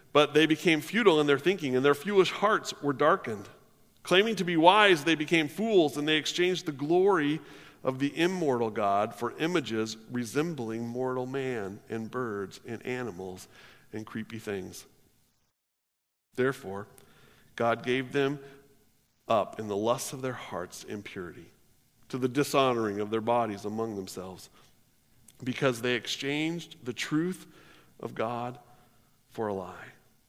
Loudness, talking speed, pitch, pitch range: -28 LUFS, 140 wpm, 130 Hz, 115-155 Hz